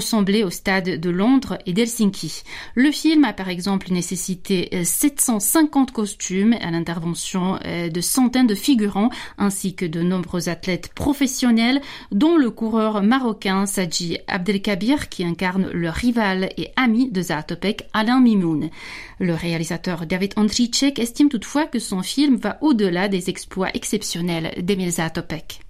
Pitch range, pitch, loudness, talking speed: 180-235 Hz, 200 Hz, -20 LUFS, 135 wpm